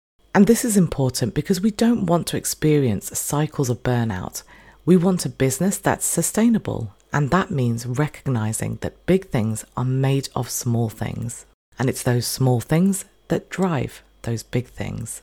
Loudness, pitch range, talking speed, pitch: -21 LUFS, 115-175 Hz, 160 wpm, 130 Hz